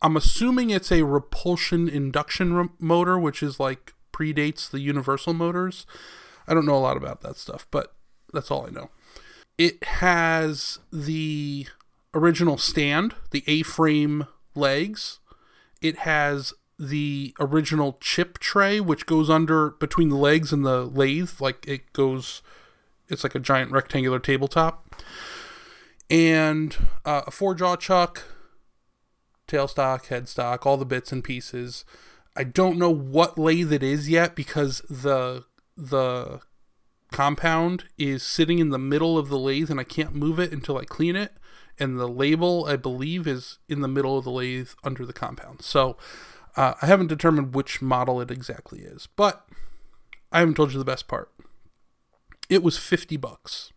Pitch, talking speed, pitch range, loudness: 150 Hz, 155 wpm, 135-170 Hz, -24 LUFS